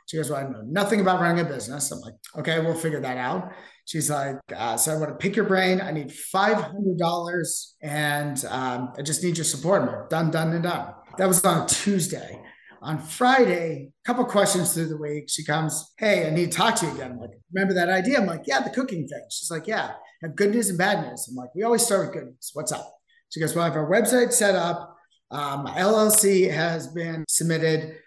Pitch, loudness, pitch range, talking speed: 170 Hz, -23 LUFS, 155-195 Hz, 235 wpm